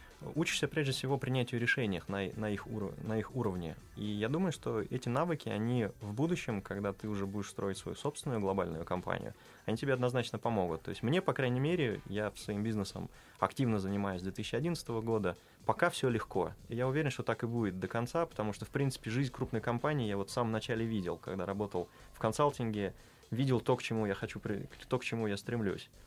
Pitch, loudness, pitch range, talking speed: 115 Hz, -36 LUFS, 105-130 Hz, 200 wpm